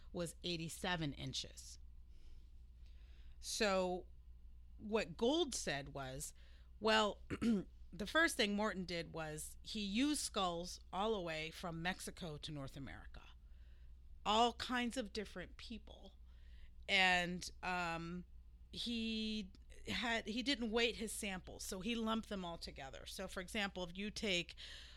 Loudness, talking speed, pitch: -40 LUFS, 125 wpm, 175 Hz